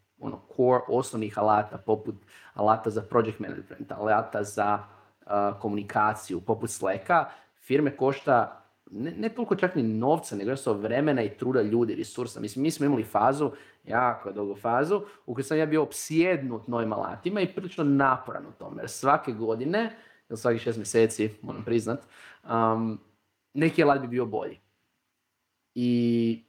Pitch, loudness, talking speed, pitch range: 120 Hz, -27 LUFS, 155 wpm, 110-140 Hz